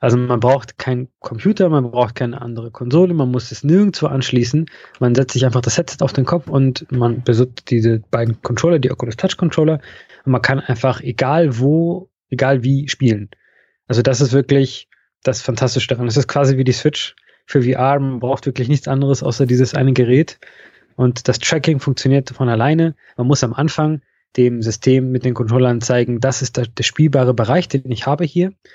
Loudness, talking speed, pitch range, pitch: -16 LUFS, 190 wpm, 125-145 Hz, 130 Hz